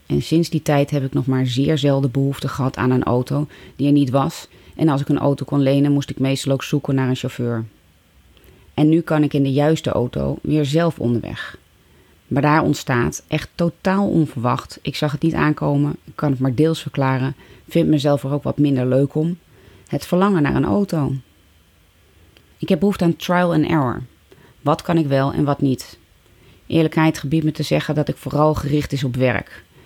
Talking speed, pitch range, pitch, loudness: 205 wpm, 130-155 Hz, 140 Hz, -19 LUFS